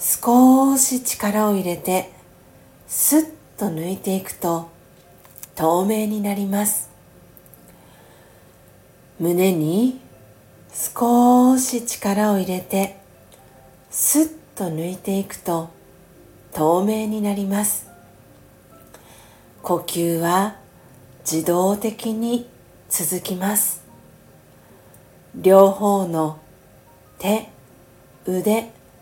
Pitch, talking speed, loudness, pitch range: 195 Hz, 130 characters per minute, -20 LUFS, 170-215 Hz